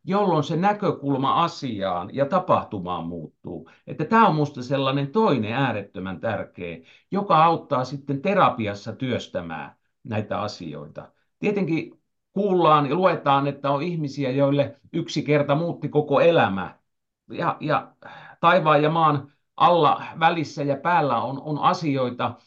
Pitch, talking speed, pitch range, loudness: 145 Hz, 125 wpm, 135-170 Hz, -22 LUFS